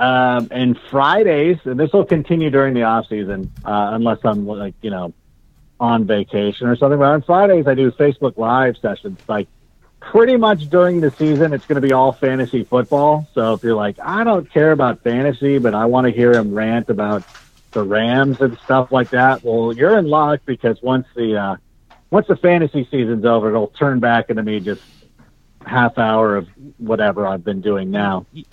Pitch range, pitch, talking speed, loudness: 110-145 Hz, 125 Hz, 195 wpm, -16 LUFS